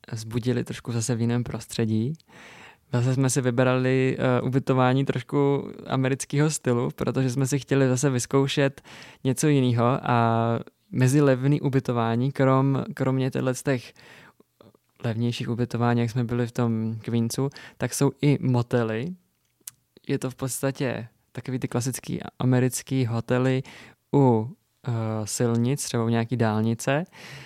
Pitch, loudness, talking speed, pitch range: 130 Hz, -25 LUFS, 130 wpm, 120-135 Hz